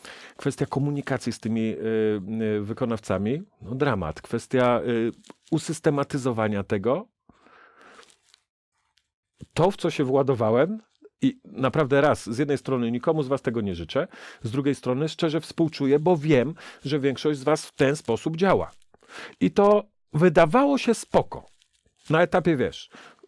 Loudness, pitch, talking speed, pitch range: -24 LUFS, 140 Hz, 135 wpm, 120-165 Hz